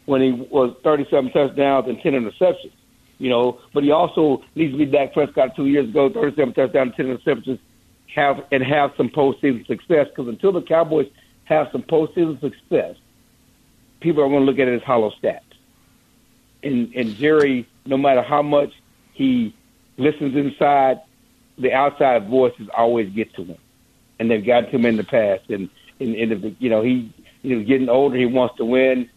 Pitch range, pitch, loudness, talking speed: 125-145 Hz, 135 Hz, -19 LUFS, 185 wpm